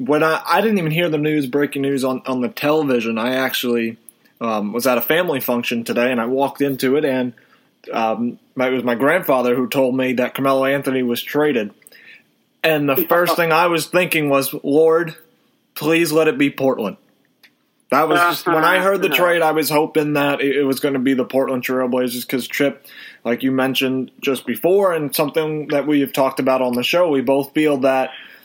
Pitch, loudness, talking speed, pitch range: 140 Hz, -18 LUFS, 205 wpm, 130-155 Hz